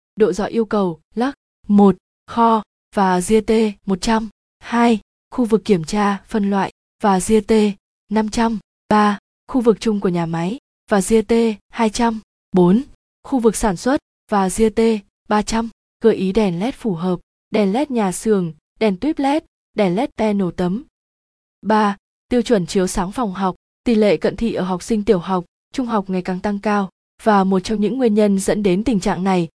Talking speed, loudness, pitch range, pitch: 180 wpm, -18 LUFS, 190-225 Hz, 210 Hz